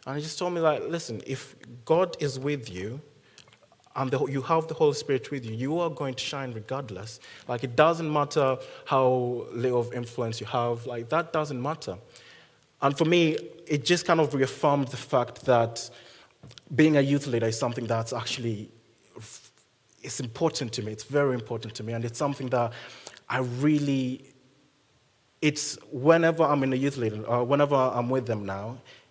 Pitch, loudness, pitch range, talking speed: 135 Hz, -27 LUFS, 120-150 Hz, 180 wpm